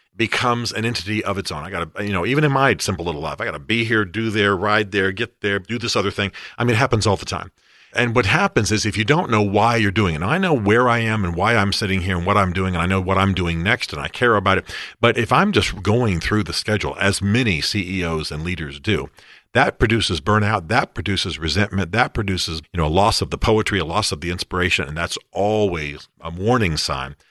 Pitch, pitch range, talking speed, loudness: 100 Hz, 90-110 Hz, 260 wpm, -19 LUFS